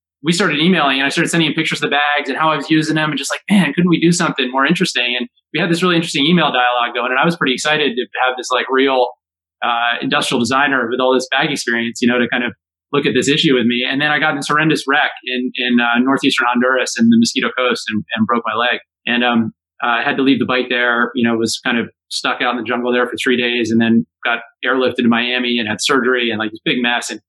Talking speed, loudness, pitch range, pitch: 275 wpm, -15 LUFS, 120-150 Hz, 130 Hz